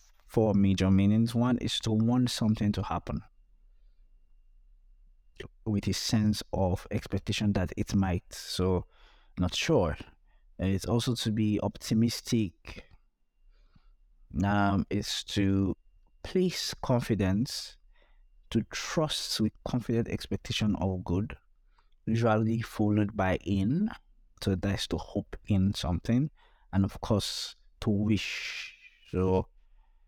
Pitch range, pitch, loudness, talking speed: 95-110 Hz, 100 Hz, -30 LUFS, 110 wpm